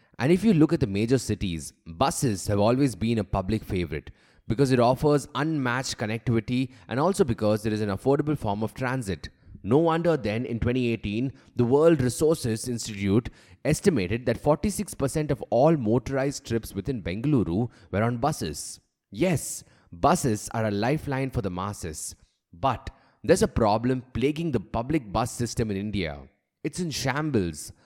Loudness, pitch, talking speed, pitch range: -26 LUFS, 120 Hz, 155 wpm, 105-140 Hz